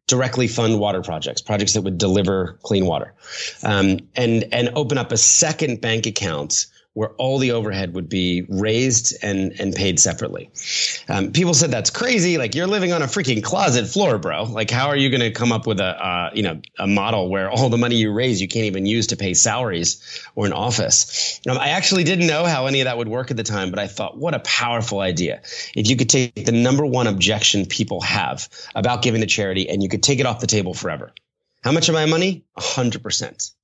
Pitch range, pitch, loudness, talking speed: 100-130 Hz, 115 Hz, -19 LUFS, 230 wpm